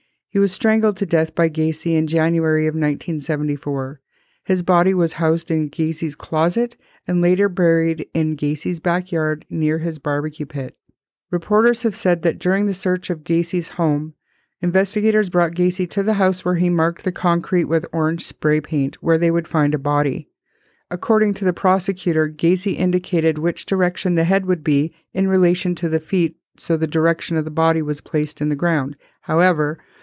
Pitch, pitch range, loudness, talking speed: 170 Hz, 155-185 Hz, -19 LUFS, 175 wpm